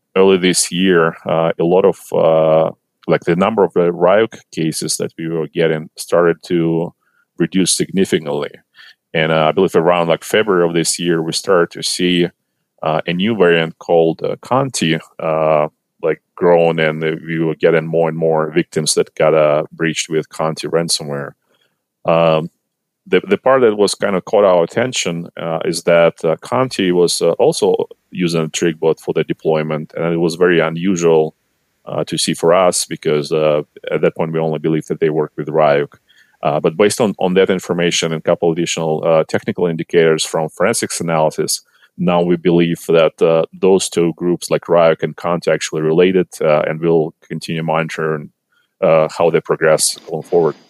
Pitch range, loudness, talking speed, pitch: 80-85 Hz, -15 LUFS, 180 wpm, 80 Hz